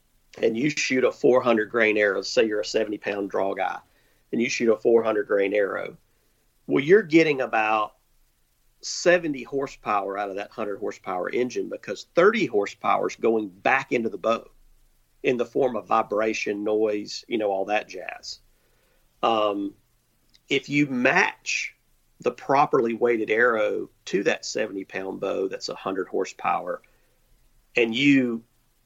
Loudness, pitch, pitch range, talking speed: -24 LUFS, 115 Hz, 105-150 Hz, 150 wpm